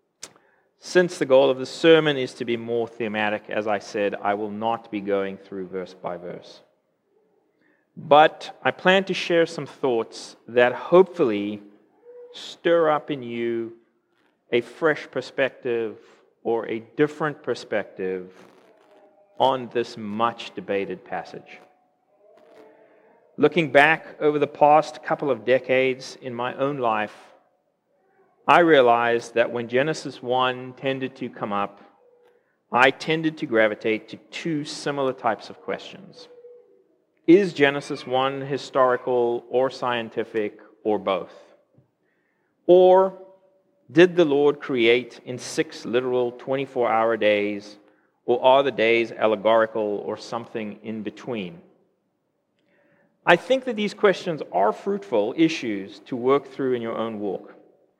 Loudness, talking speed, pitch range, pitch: -22 LUFS, 125 wpm, 115-155 Hz, 130 Hz